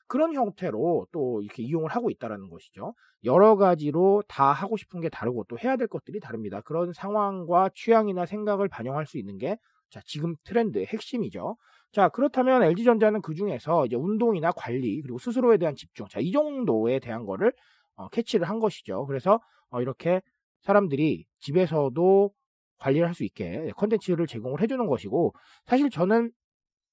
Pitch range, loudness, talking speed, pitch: 150-220 Hz, -26 LUFS, 370 characters per minute, 185 Hz